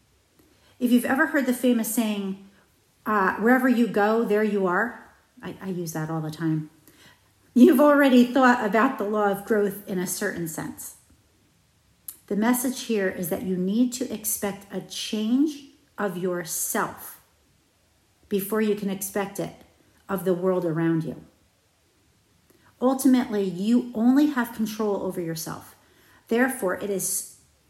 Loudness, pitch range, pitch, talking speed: -24 LUFS, 185-245 Hz, 205 Hz, 145 wpm